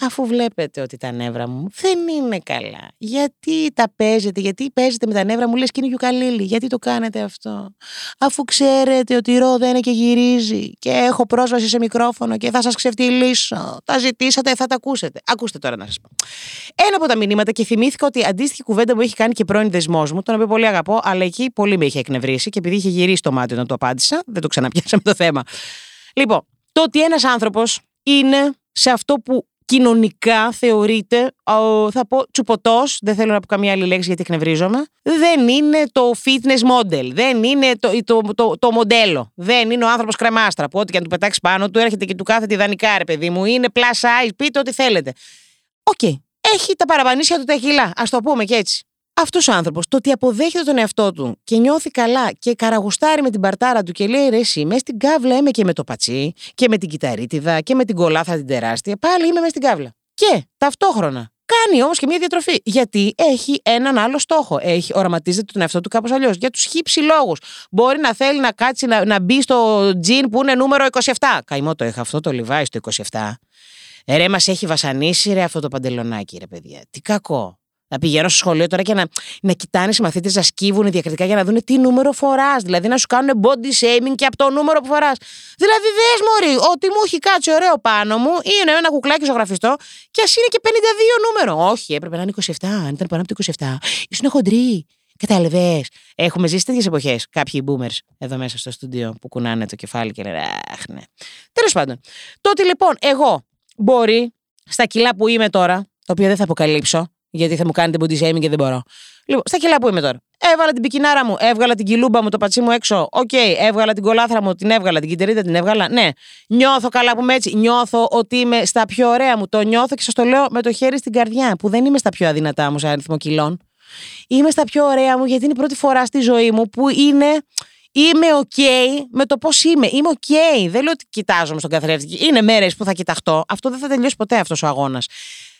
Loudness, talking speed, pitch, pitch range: -16 LUFS, 215 wpm, 230 Hz, 180-265 Hz